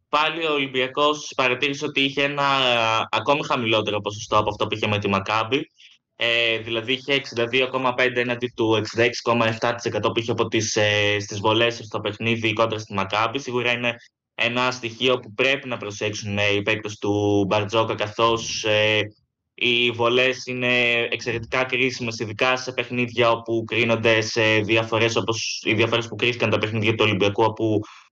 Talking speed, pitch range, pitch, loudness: 155 wpm, 110-125 Hz, 115 Hz, -21 LUFS